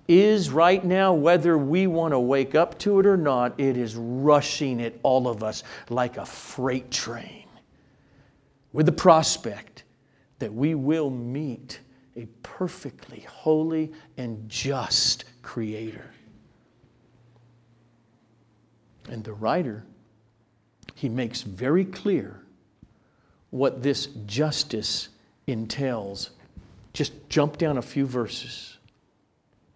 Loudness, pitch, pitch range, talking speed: -24 LUFS, 130 Hz, 115-155 Hz, 110 wpm